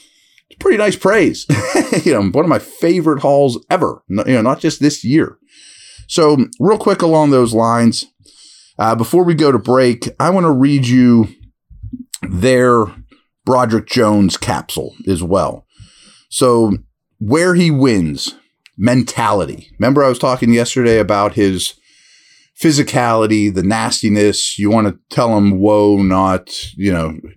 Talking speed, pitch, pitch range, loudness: 145 wpm, 120 Hz, 105-140 Hz, -13 LUFS